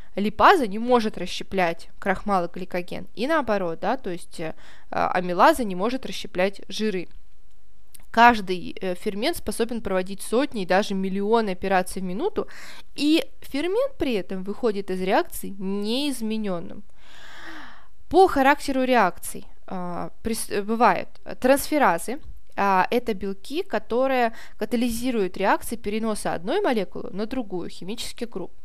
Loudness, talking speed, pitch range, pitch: -24 LUFS, 115 wpm, 190-245 Hz, 215 Hz